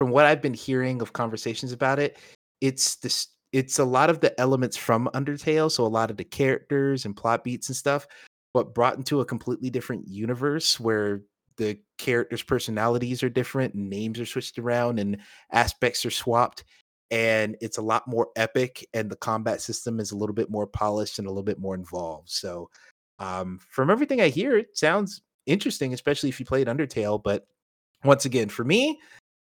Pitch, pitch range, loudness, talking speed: 120 Hz, 110-135 Hz, -25 LUFS, 185 wpm